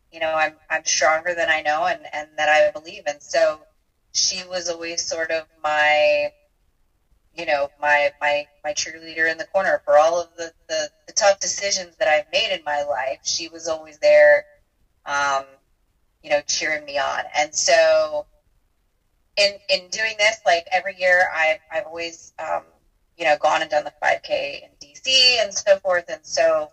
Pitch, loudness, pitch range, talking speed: 160 Hz, -20 LUFS, 150-195 Hz, 185 wpm